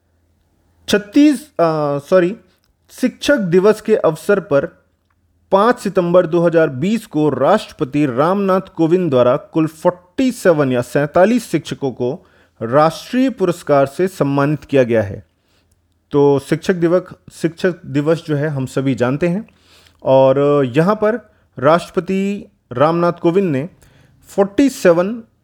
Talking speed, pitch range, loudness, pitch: 115 wpm, 135-190 Hz, -16 LUFS, 160 Hz